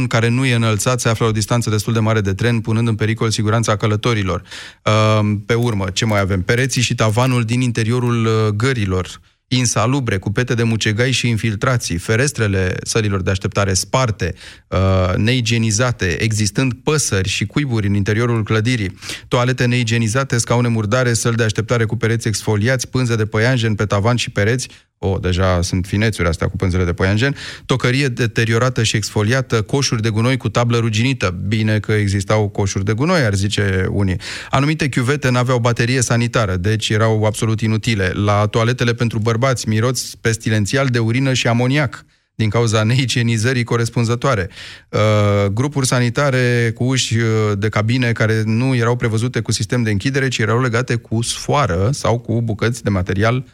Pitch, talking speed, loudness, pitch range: 115 Hz, 160 wpm, -17 LUFS, 105-125 Hz